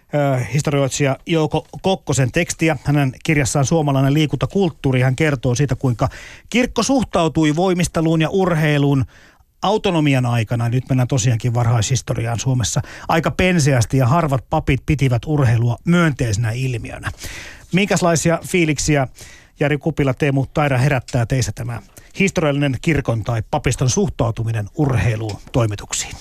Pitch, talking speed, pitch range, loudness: 140 Hz, 110 wpm, 120-155 Hz, -18 LUFS